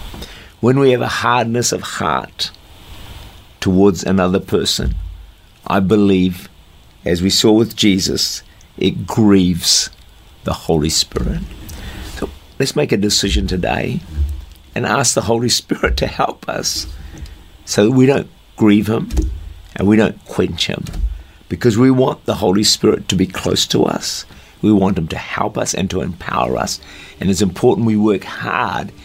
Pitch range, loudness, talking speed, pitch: 80-110 Hz, -16 LUFS, 155 wpm, 95 Hz